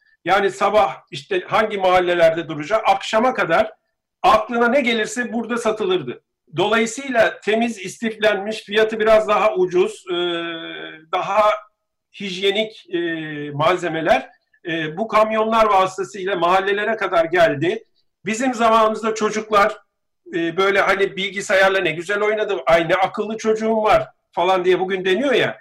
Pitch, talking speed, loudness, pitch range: 210 Hz, 110 wpm, -19 LUFS, 190-225 Hz